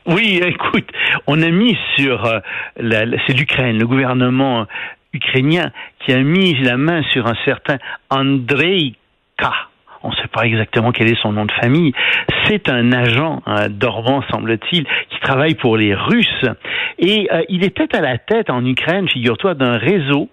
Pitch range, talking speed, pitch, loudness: 120-165 Hz, 170 wpm, 135 Hz, -15 LUFS